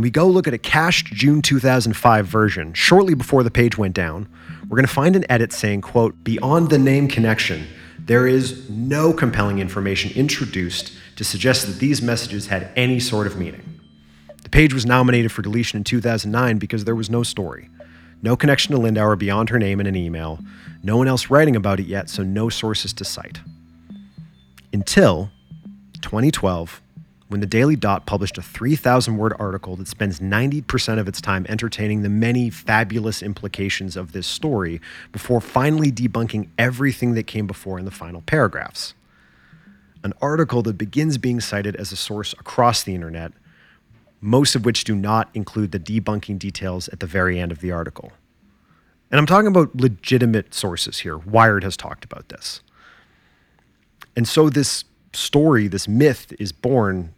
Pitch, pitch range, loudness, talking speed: 110 Hz, 95-125 Hz, -19 LUFS, 170 wpm